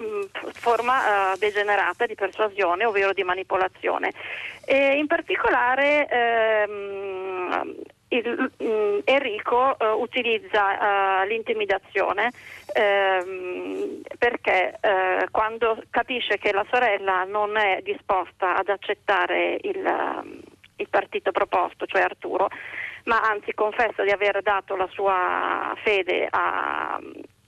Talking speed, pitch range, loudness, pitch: 105 wpm, 195-255 Hz, -23 LUFS, 215 Hz